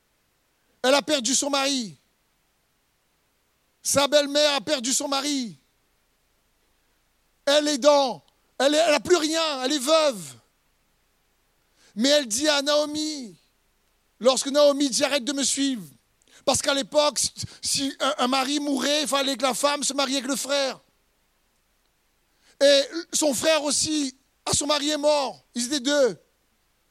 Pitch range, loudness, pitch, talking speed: 270-295 Hz, -22 LUFS, 285 Hz, 140 wpm